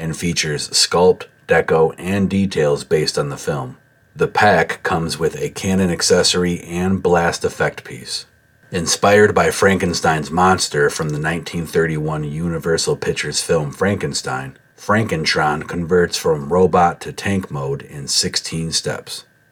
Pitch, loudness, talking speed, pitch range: 85 Hz, -17 LUFS, 130 wpm, 80-95 Hz